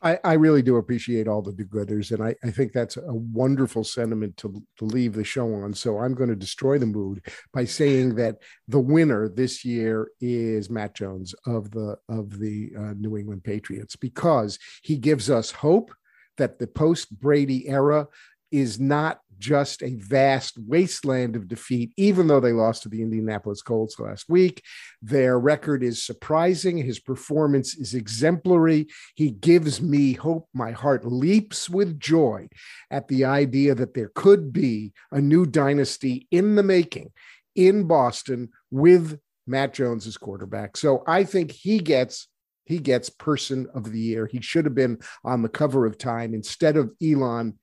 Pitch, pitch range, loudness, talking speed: 130 Hz, 115-150 Hz, -23 LUFS, 170 wpm